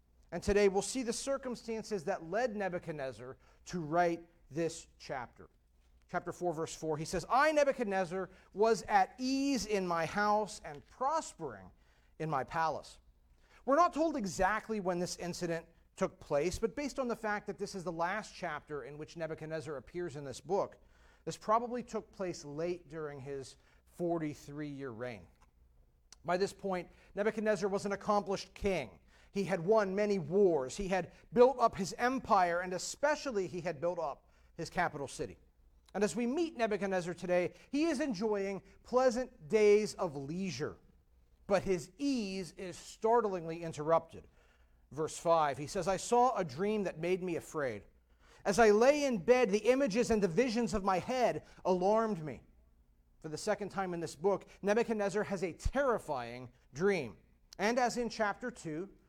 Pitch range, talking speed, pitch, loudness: 155-215 Hz, 160 wpm, 185 Hz, -34 LUFS